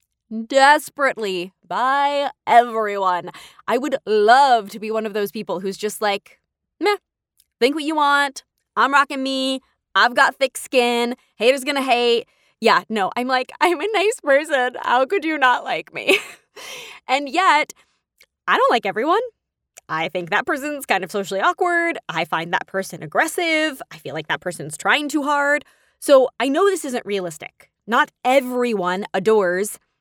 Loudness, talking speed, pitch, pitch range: -19 LUFS, 160 wpm, 255 Hz, 210-295 Hz